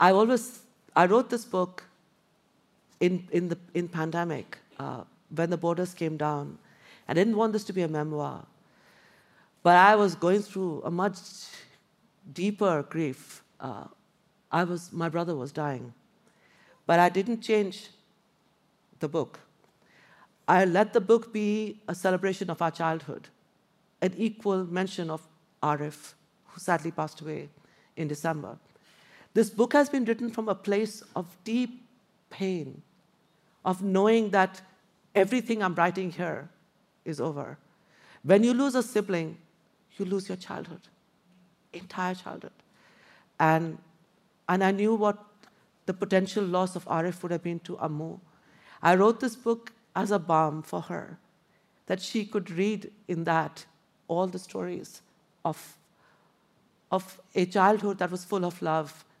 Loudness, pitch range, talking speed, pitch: -28 LUFS, 170-210 Hz, 145 wpm, 185 Hz